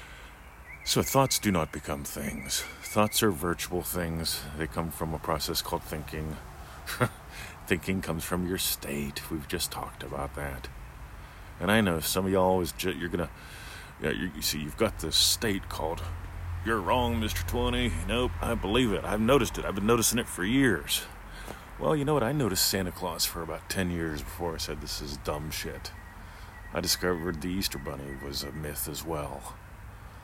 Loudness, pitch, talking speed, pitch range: -29 LUFS, 85 Hz, 185 wpm, 75-95 Hz